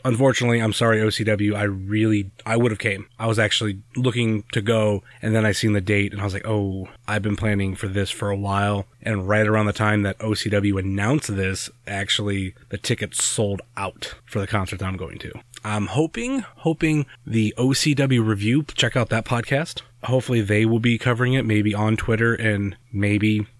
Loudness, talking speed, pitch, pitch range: -22 LUFS, 195 wpm, 110 Hz, 100-120 Hz